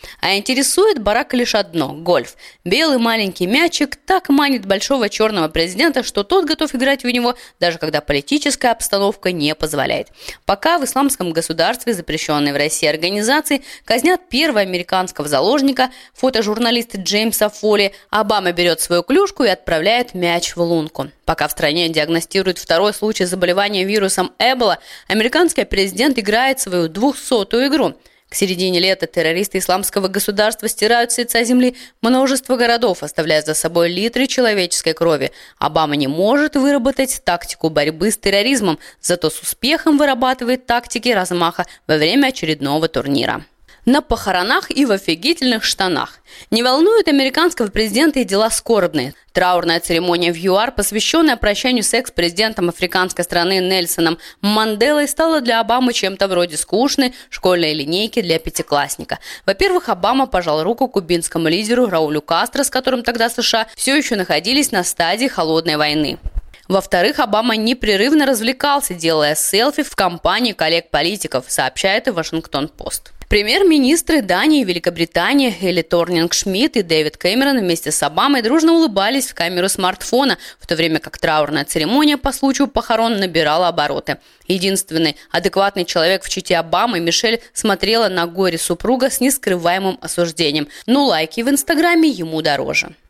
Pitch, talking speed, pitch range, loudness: 205 Hz, 140 wpm, 170-260 Hz, -16 LUFS